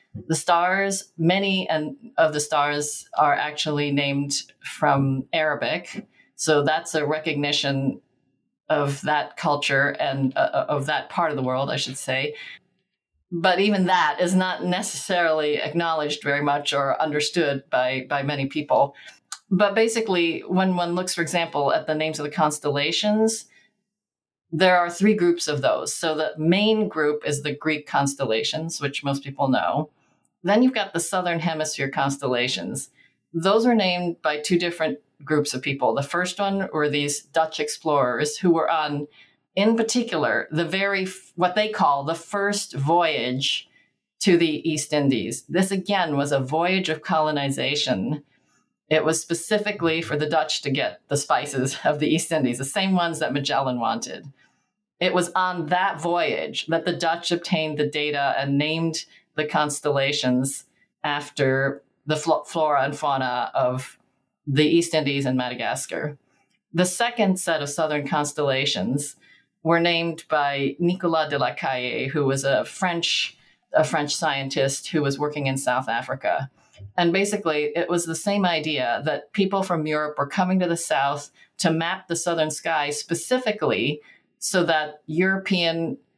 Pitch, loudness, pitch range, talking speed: 155 Hz, -23 LUFS, 145-175 Hz, 155 wpm